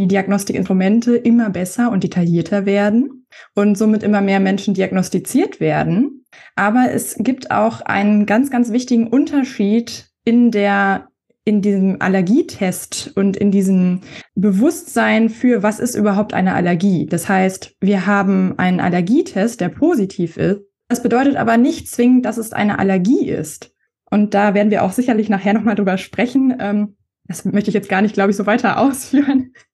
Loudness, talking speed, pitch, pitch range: -16 LUFS, 155 wpm, 205 Hz, 195-240 Hz